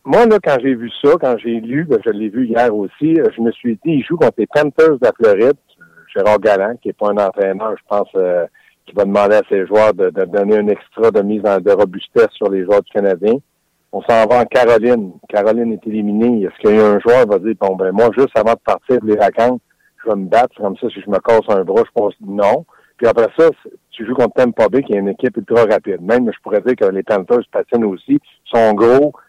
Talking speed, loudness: 255 wpm, -14 LUFS